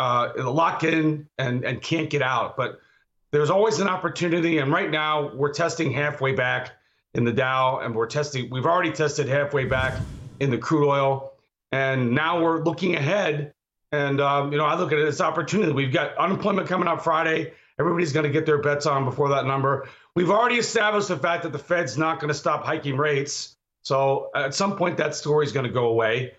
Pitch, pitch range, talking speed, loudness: 150 Hz, 135-165 Hz, 210 wpm, -23 LUFS